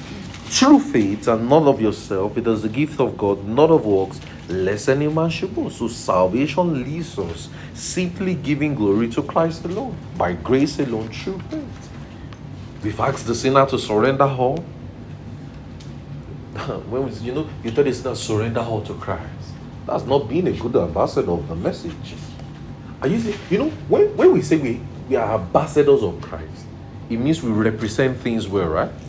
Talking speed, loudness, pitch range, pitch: 175 wpm, -20 LUFS, 110-150 Hz, 130 Hz